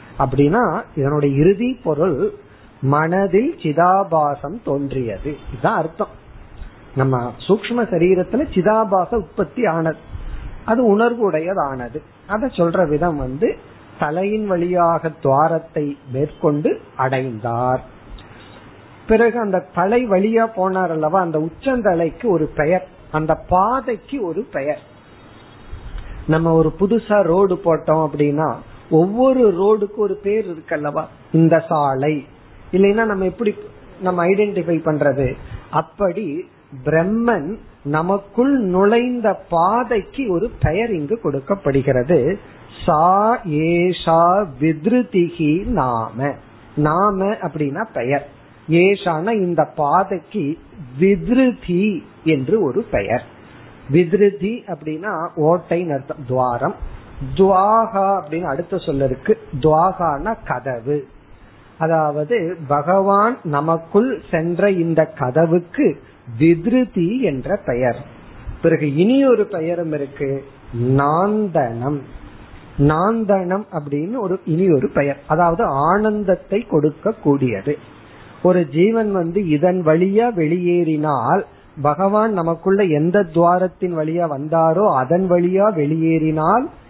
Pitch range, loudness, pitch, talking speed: 145-200 Hz, -18 LUFS, 170 Hz, 85 wpm